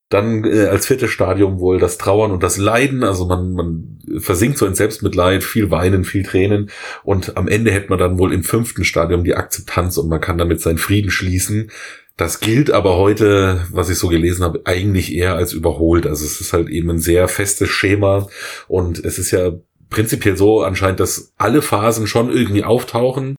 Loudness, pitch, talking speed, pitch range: -16 LUFS, 95 Hz, 195 wpm, 90-105 Hz